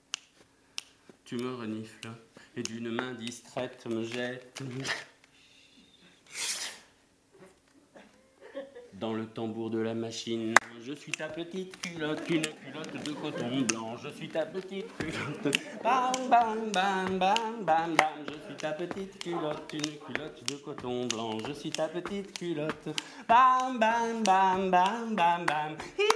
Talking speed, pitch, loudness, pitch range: 130 wpm, 155 Hz, -31 LUFS, 125-190 Hz